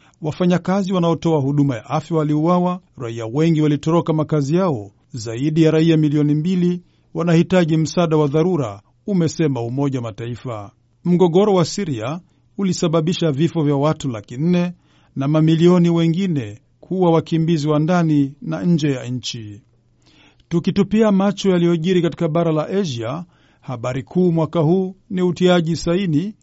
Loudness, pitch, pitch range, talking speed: -18 LUFS, 160 Hz, 140-175 Hz, 125 wpm